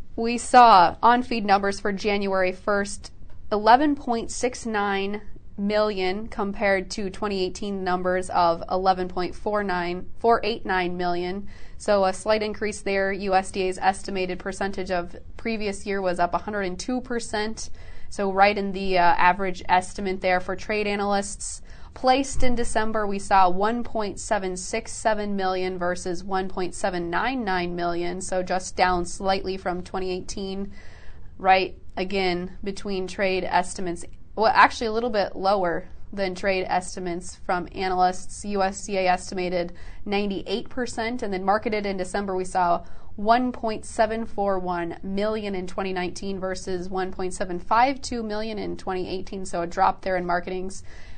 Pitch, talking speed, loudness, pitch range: 195 Hz, 115 wpm, -25 LUFS, 185-210 Hz